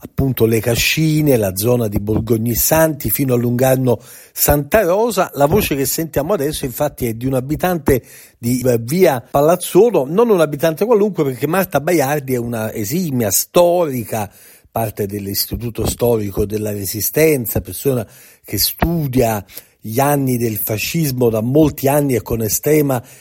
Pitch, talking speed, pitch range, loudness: 130 Hz, 140 wpm, 115-150 Hz, -16 LUFS